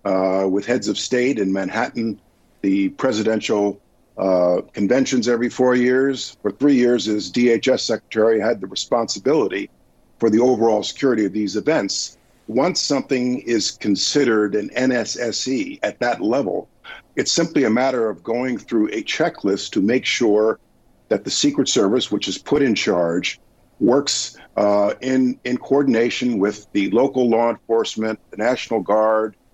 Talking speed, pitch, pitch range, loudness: 150 wpm, 110 Hz, 100-125 Hz, -19 LUFS